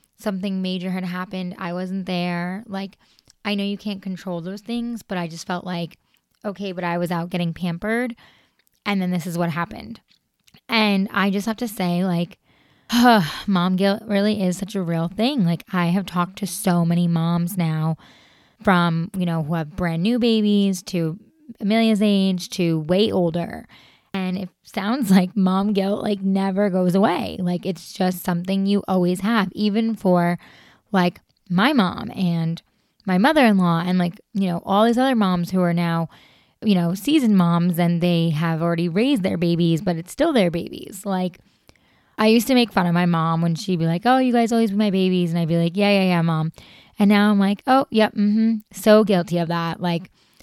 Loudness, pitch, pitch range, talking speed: -21 LUFS, 185 Hz, 175-210 Hz, 195 wpm